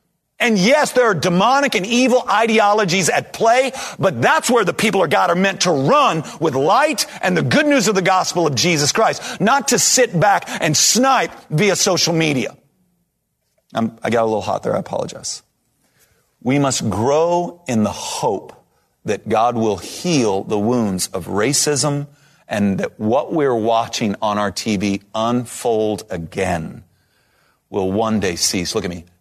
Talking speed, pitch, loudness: 170 wpm, 155 Hz, -17 LUFS